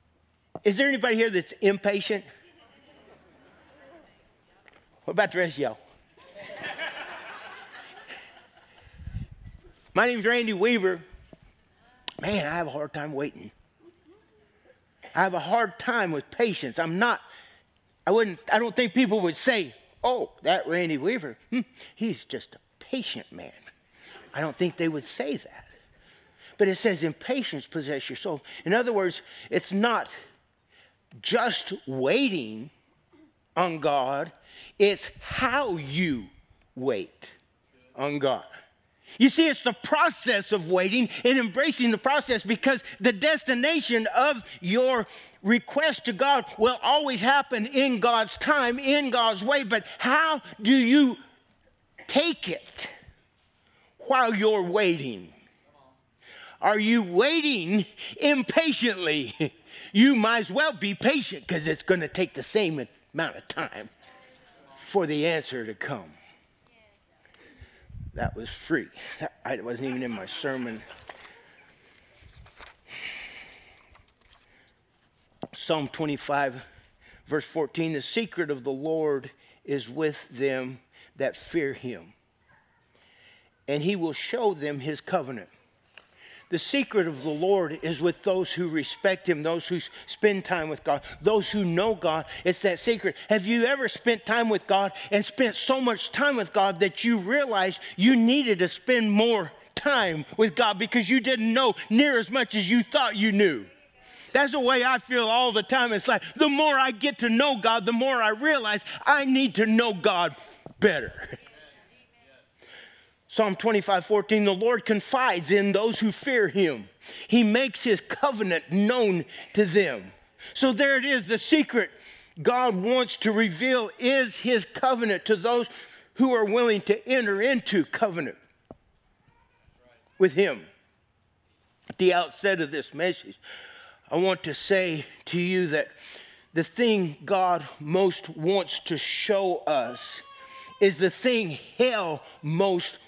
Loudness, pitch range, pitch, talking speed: -25 LUFS, 170-245 Hz, 210 Hz, 140 wpm